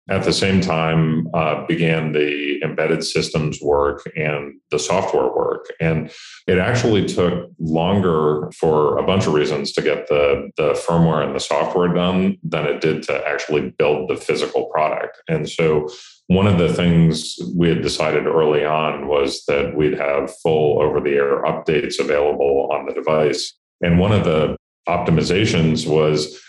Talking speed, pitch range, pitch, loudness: 165 wpm, 75-95 Hz, 80 Hz, -18 LUFS